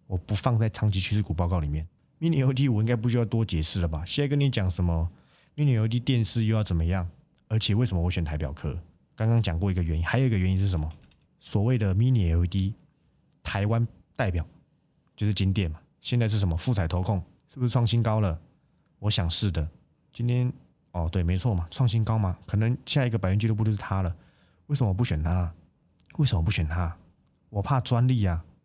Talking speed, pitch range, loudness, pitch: 335 characters per minute, 85-120 Hz, -27 LUFS, 100 Hz